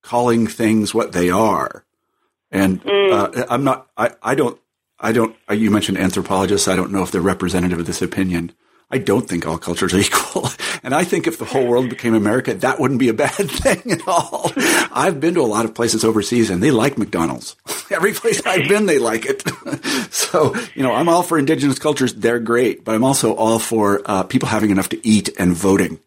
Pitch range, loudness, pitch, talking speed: 95-125 Hz, -17 LUFS, 110 Hz, 210 wpm